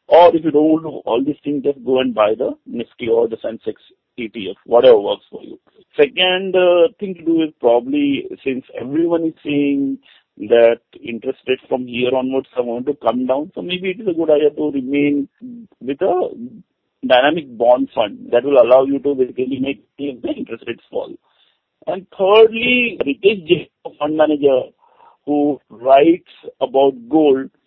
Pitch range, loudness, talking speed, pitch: 135-200 Hz, -16 LUFS, 170 wpm, 150 Hz